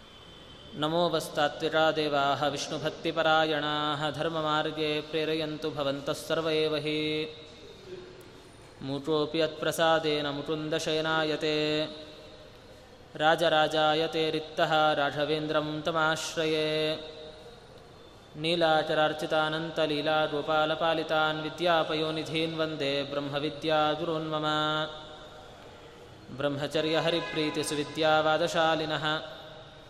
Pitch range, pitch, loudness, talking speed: 150-160 Hz, 155 Hz, -28 LUFS, 45 wpm